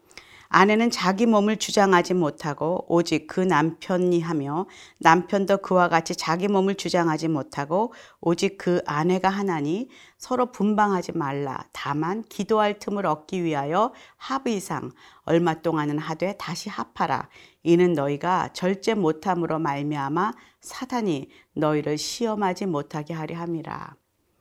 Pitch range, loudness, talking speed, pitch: 160-200 Hz, -24 LUFS, 290 characters per minute, 175 Hz